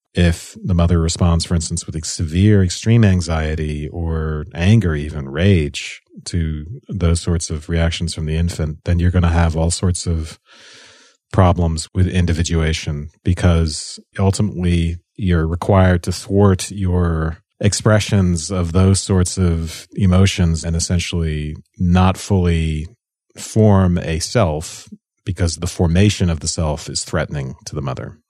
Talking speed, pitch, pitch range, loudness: 140 wpm, 85 Hz, 80-95 Hz, -18 LUFS